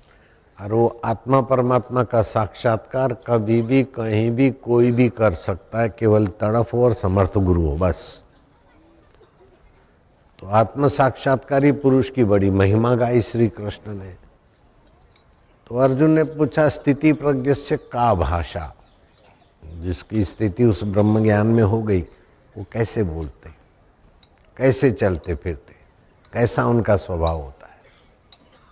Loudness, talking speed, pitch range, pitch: -20 LUFS, 125 wpm, 95-125 Hz, 110 Hz